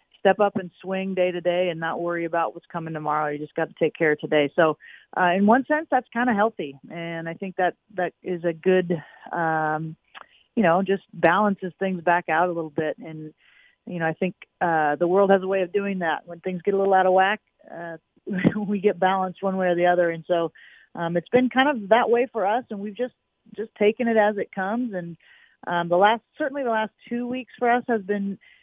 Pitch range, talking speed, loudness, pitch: 170-210 Hz, 240 wpm, -23 LUFS, 185 Hz